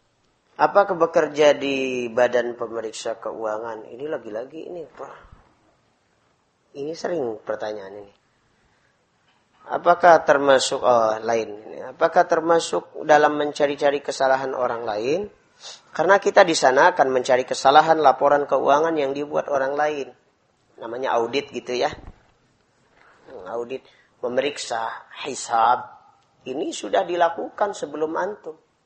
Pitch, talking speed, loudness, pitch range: 140 Hz, 100 wpm, -21 LUFS, 125-165 Hz